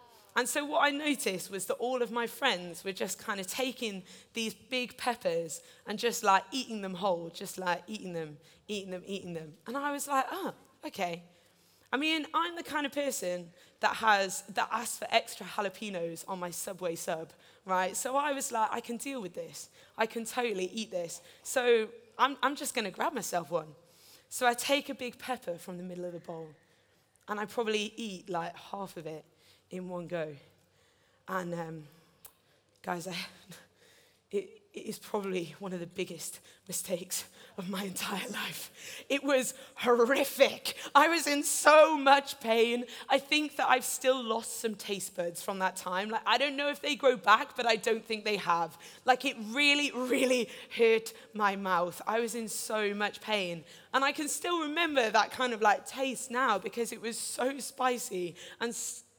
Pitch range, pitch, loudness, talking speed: 185-260 Hz, 220 Hz, -31 LUFS, 190 wpm